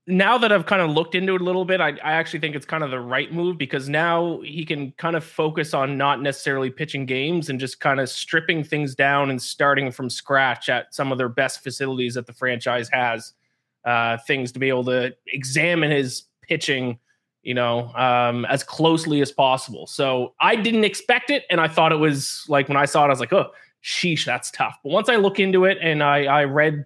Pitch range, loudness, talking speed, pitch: 130-165 Hz, -21 LUFS, 230 wpm, 145 Hz